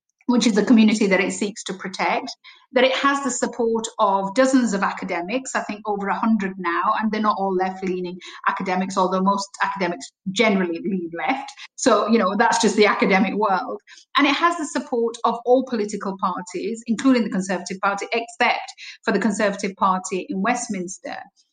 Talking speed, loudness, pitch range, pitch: 180 wpm, -21 LUFS, 190-240 Hz, 215 Hz